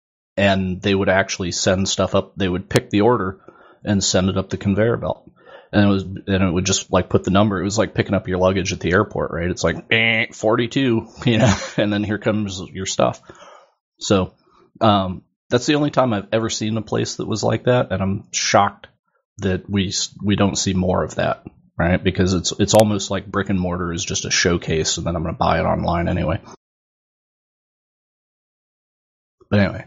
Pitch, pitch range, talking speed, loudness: 100 Hz, 95-110 Hz, 205 wpm, -19 LUFS